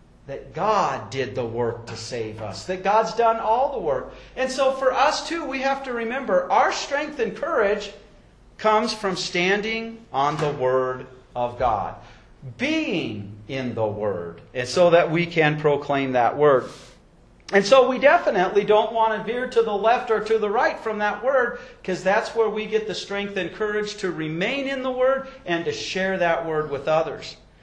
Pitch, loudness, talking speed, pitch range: 205 Hz, -22 LUFS, 185 wpm, 150-230 Hz